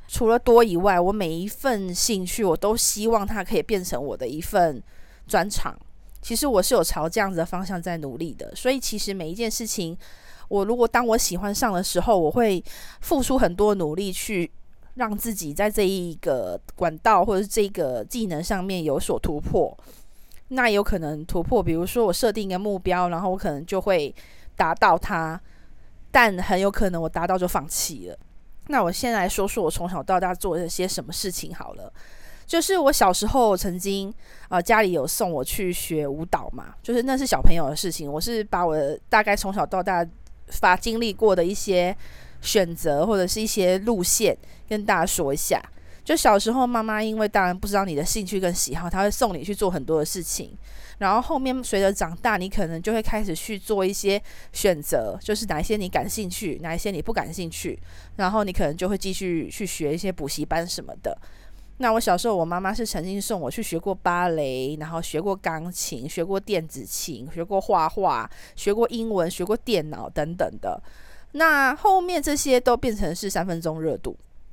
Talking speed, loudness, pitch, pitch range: 290 characters per minute, -24 LUFS, 195 Hz, 175-220 Hz